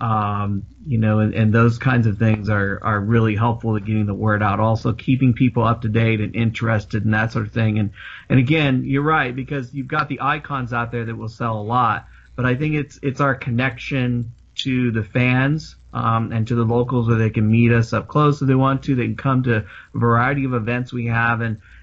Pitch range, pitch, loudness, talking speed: 110-130 Hz, 115 Hz, -20 LUFS, 235 wpm